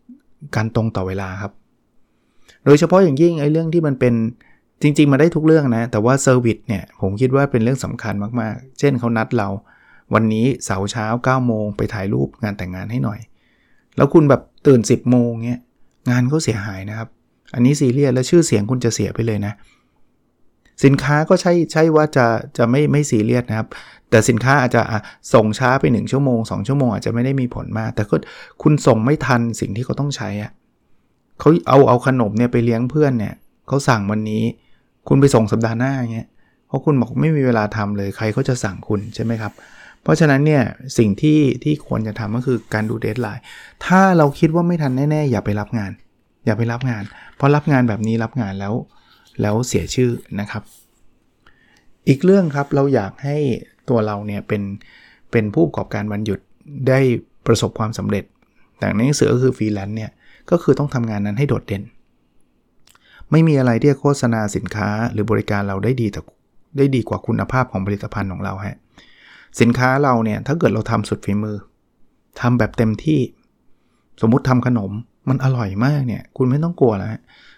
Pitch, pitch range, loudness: 120 Hz, 105-135 Hz, -18 LUFS